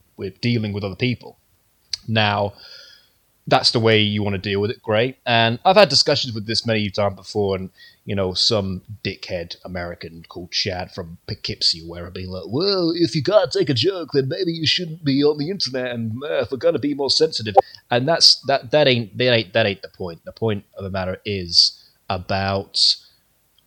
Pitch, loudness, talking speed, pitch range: 110 Hz, -19 LUFS, 205 wpm, 100-135 Hz